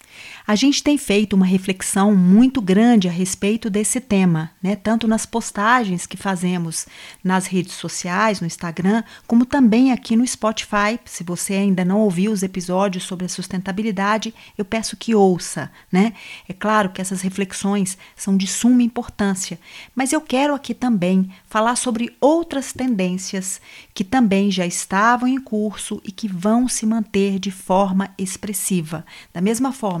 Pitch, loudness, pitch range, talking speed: 205 Hz, -19 LUFS, 190-230 Hz, 155 wpm